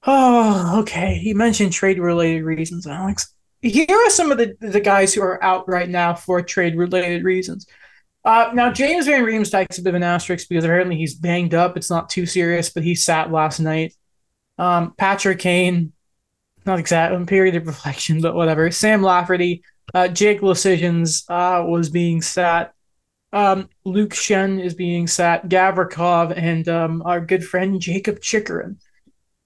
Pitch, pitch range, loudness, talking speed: 180 Hz, 170-195 Hz, -18 LUFS, 160 wpm